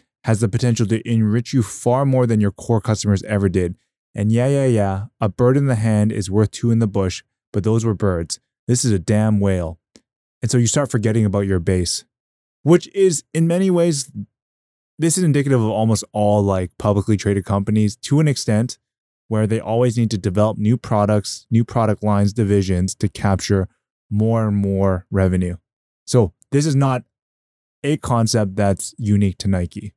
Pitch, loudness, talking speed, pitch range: 110 Hz, -19 LUFS, 185 wpm, 100-120 Hz